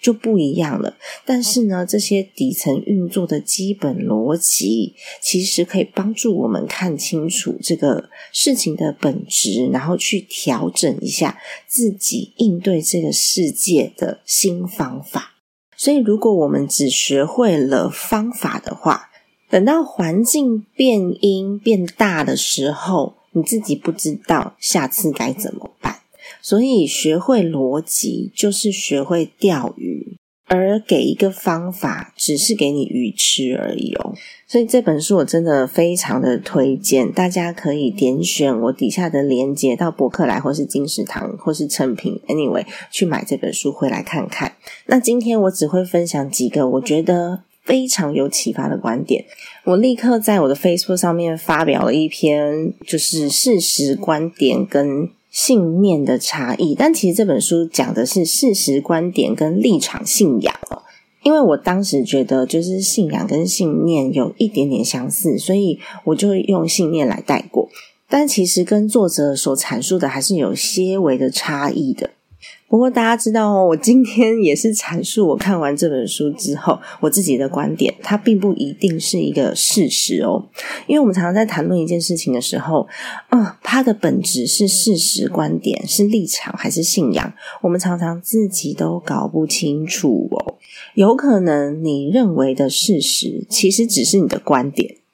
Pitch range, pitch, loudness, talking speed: 155-220 Hz, 185 Hz, -17 LUFS, 250 characters per minute